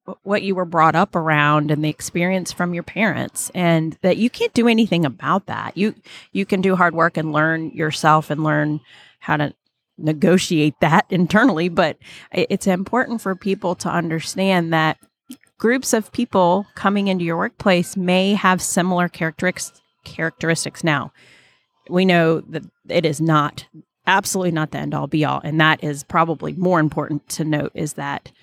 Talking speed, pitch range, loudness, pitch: 170 wpm, 155-190 Hz, -19 LUFS, 175 Hz